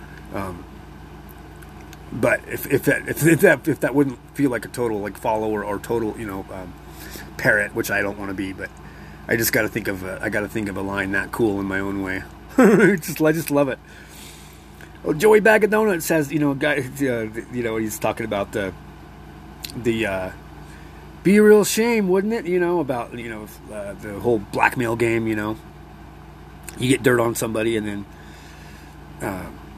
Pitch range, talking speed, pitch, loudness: 95-145 Hz, 190 wpm, 110 Hz, -21 LUFS